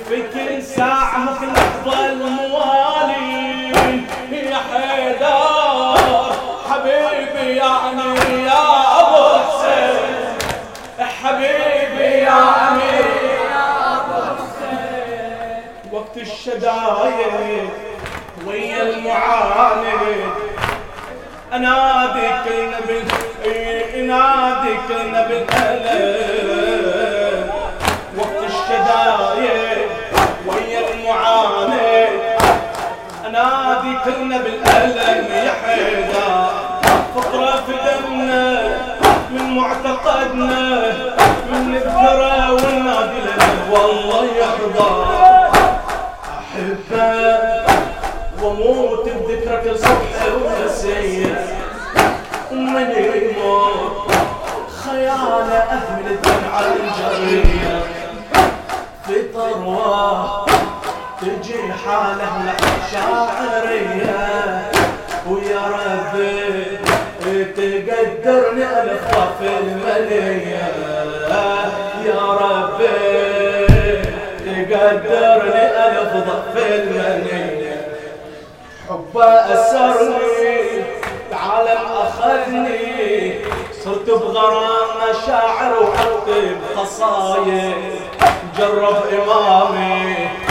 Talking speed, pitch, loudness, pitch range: 55 wpm, 230 Hz, -16 LUFS, 210-265 Hz